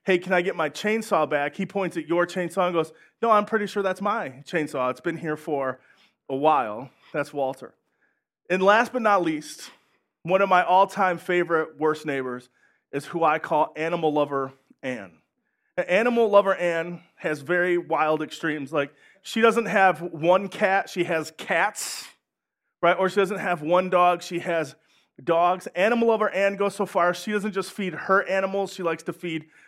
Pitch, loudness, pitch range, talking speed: 175 Hz, -24 LUFS, 155-195 Hz, 185 wpm